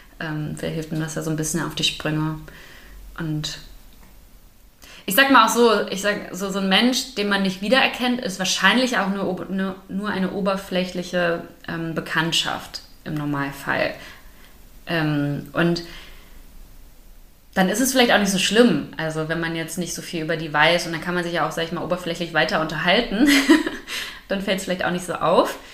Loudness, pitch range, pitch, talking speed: -21 LUFS, 160-195 Hz, 175 Hz, 185 wpm